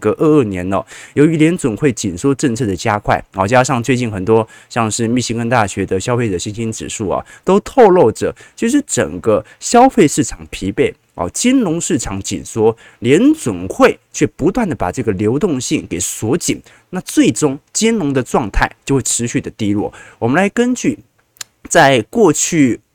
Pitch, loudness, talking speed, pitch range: 125 Hz, -15 LUFS, 260 characters per minute, 105-160 Hz